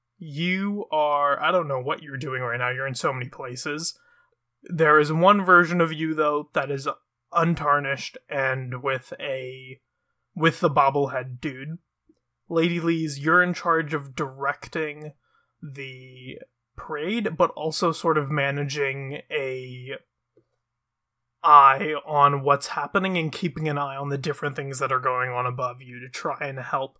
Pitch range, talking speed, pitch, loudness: 130-165 Hz, 155 wpm, 145 Hz, -23 LUFS